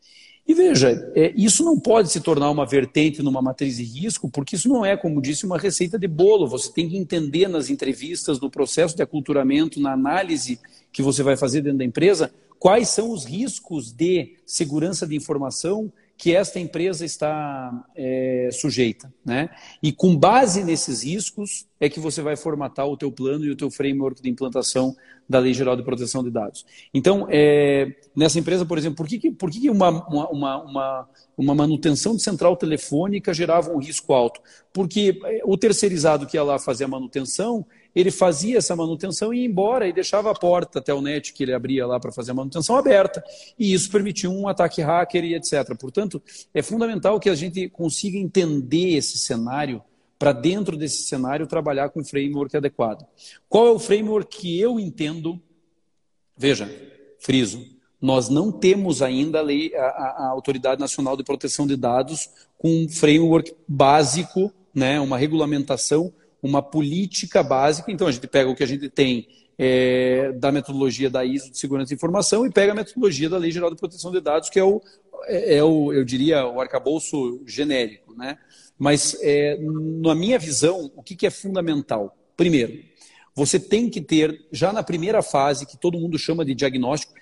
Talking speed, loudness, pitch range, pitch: 180 wpm, -21 LUFS, 140-190 Hz, 155 Hz